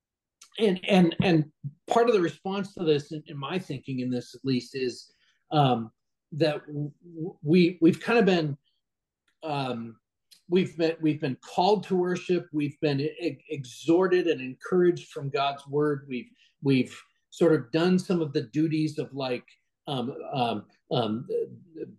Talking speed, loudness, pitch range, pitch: 160 wpm, -27 LUFS, 140-180 Hz, 155 Hz